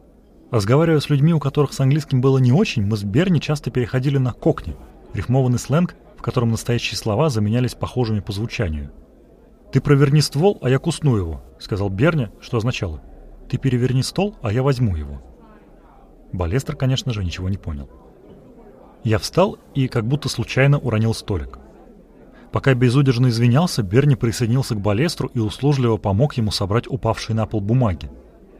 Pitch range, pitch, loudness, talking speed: 105-135 Hz, 125 Hz, -20 LUFS, 160 wpm